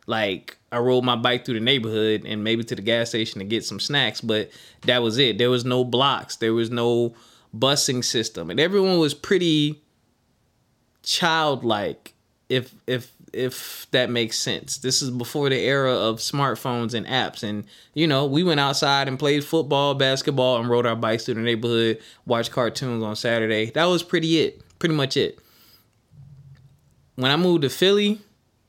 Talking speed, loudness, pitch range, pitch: 175 wpm, -22 LUFS, 115-140 Hz, 125 Hz